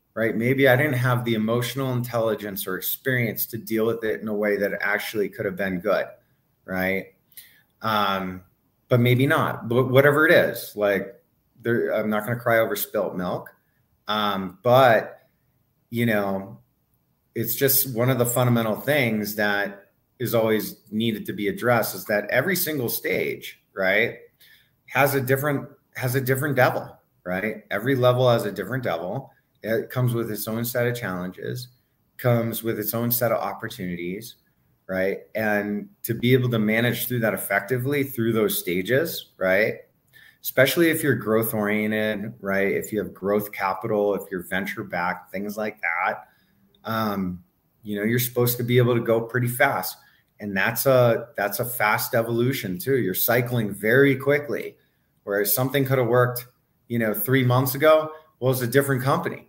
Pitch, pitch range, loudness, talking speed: 115 Hz, 105-130 Hz, -23 LUFS, 165 wpm